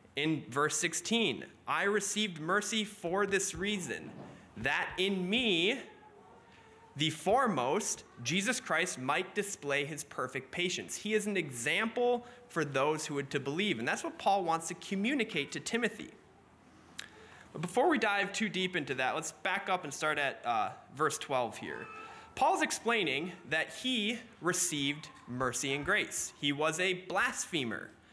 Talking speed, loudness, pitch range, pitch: 150 wpm, -33 LUFS, 150-210 Hz, 185 Hz